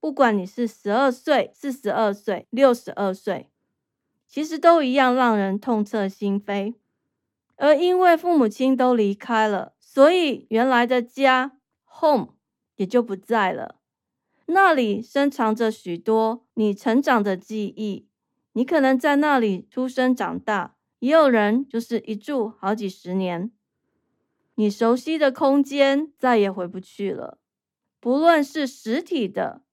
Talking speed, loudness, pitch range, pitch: 210 characters per minute, -21 LUFS, 210-275 Hz, 240 Hz